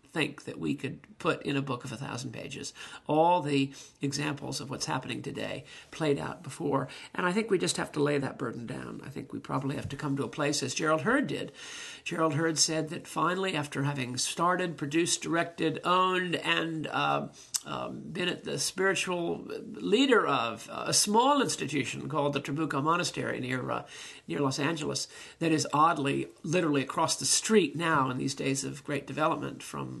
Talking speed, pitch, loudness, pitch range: 190 wpm, 150 Hz, -30 LUFS, 140-170 Hz